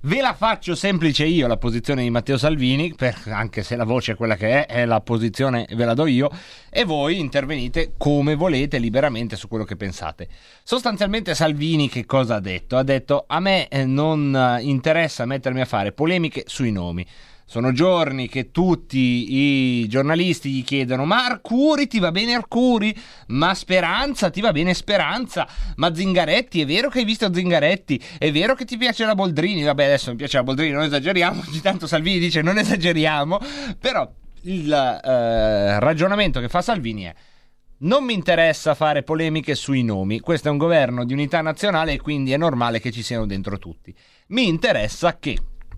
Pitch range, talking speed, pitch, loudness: 125-180 Hz, 180 wpm, 150 Hz, -20 LUFS